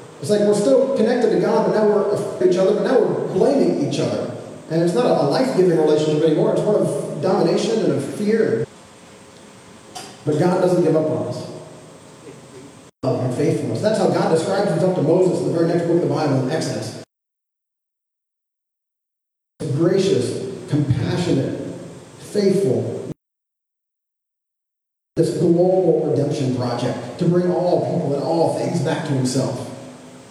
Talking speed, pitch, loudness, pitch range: 150 wpm, 165 Hz, -19 LUFS, 150-190 Hz